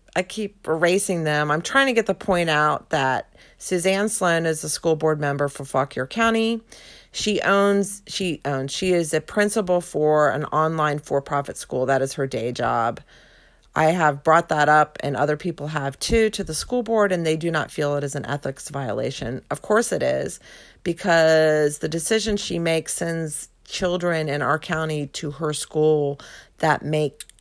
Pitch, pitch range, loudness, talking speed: 160 Hz, 150-185 Hz, -22 LUFS, 185 wpm